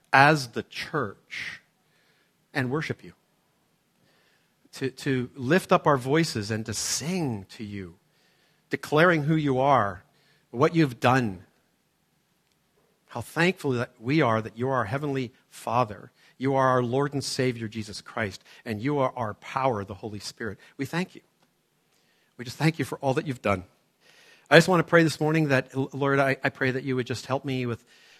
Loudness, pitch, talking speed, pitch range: -26 LUFS, 130 Hz, 175 wpm, 115-145 Hz